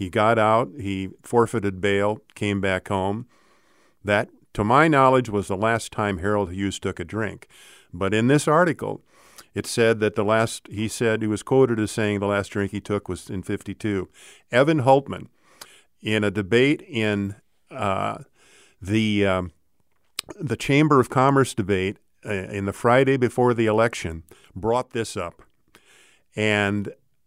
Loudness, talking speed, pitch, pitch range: -22 LUFS, 155 wpm, 105 Hz, 100-115 Hz